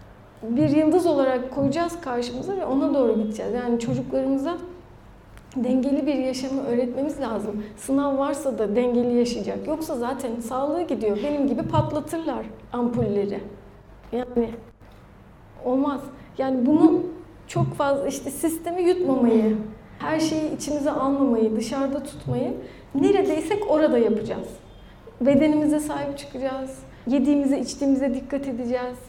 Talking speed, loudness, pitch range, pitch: 110 wpm, -24 LUFS, 245-295 Hz, 270 Hz